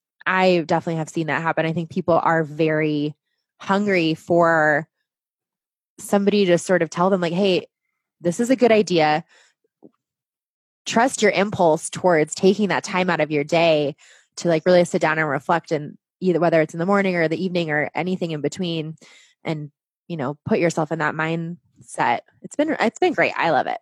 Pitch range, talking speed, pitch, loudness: 155-185 Hz, 190 wpm, 170 Hz, -20 LUFS